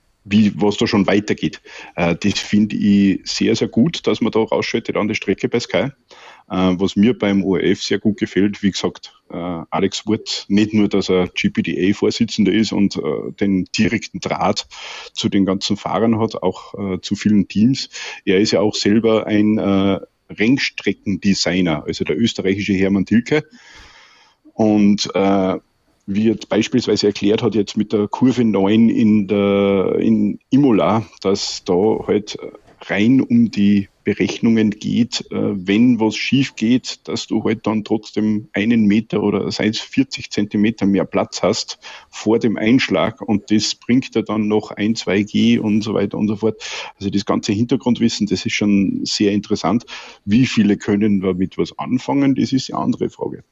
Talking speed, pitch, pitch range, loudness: 165 wpm, 105 Hz, 100-110 Hz, -17 LUFS